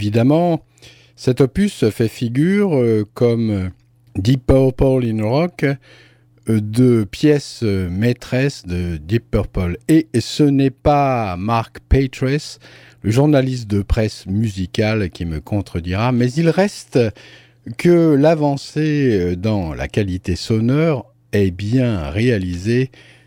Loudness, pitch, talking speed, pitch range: -17 LUFS, 120 Hz, 110 wpm, 100-135 Hz